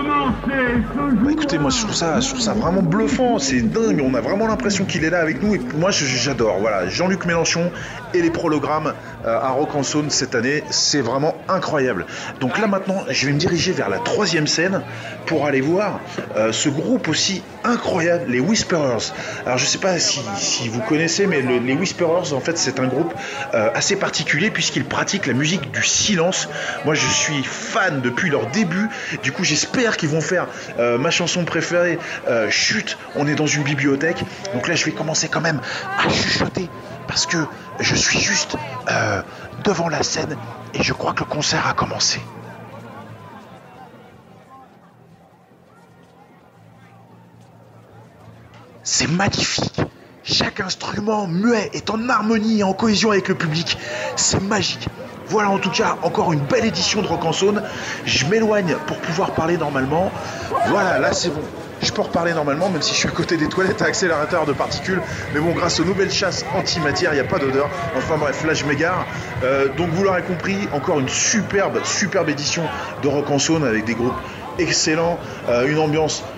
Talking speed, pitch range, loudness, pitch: 175 wpm, 145-195 Hz, -19 LUFS, 165 Hz